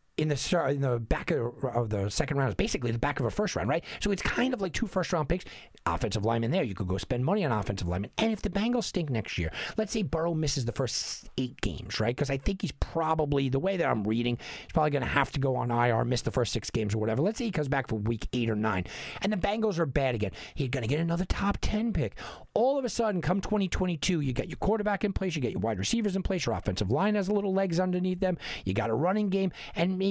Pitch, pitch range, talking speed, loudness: 145 Hz, 120-190 Hz, 275 wpm, -29 LUFS